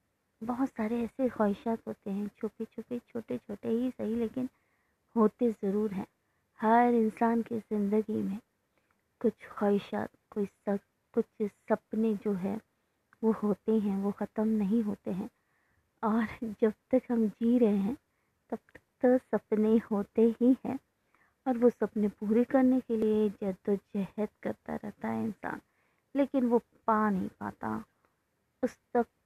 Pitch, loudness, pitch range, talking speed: 220 Hz, -31 LUFS, 210-235 Hz, 140 wpm